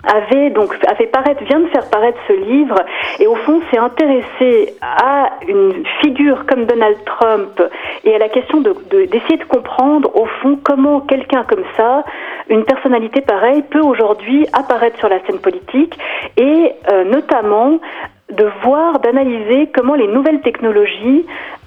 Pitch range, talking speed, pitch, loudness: 235-310 Hz, 155 wpm, 275 Hz, -13 LUFS